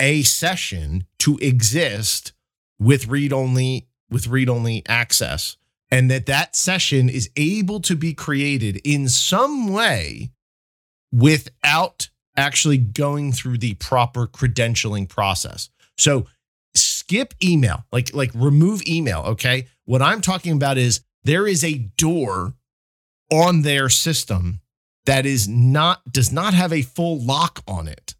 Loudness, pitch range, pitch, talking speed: -19 LUFS, 115-155 Hz, 130 Hz, 130 wpm